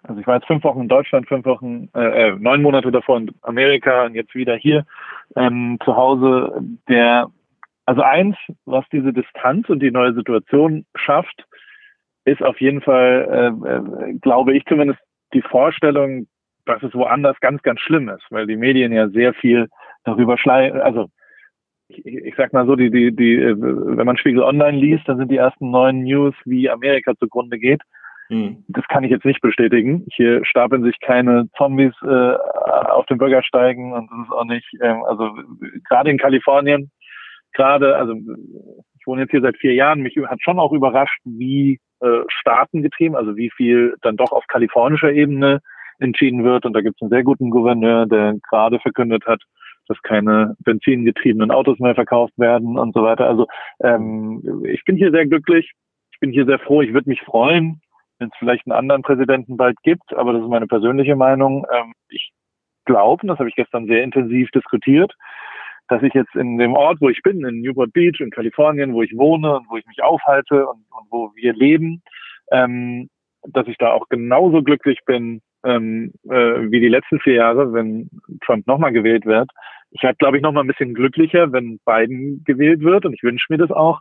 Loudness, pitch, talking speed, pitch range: -16 LUFS, 130 Hz, 185 wpm, 120-140 Hz